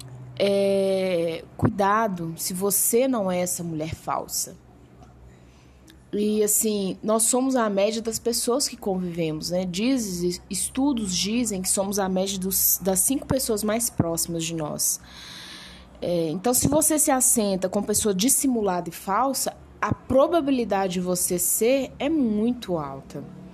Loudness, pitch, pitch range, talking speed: -23 LUFS, 195 Hz, 175-235 Hz, 140 wpm